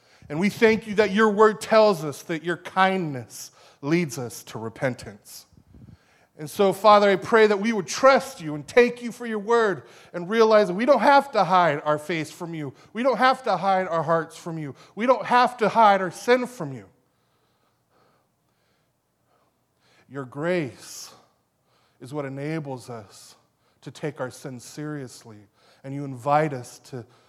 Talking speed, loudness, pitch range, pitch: 170 wpm, -22 LUFS, 140-215 Hz, 165 Hz